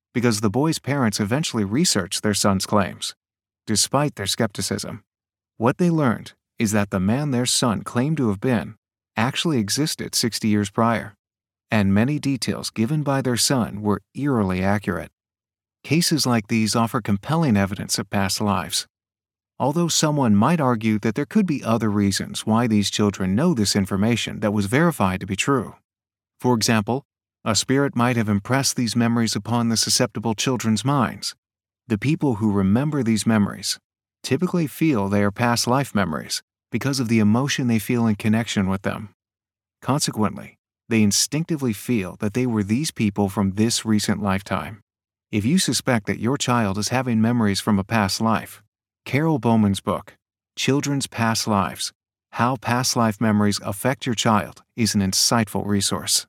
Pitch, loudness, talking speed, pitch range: 110 Hz, -21 LUFS, 160 wpm, 100-125 Hz